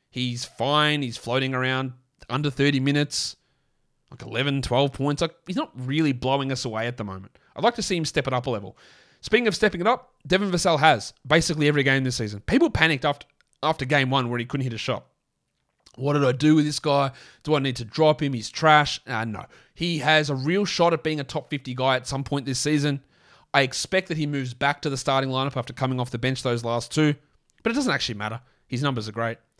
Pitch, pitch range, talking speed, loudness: 140 Hz, 125-150 Hz, 235 wpm, -24 LUFS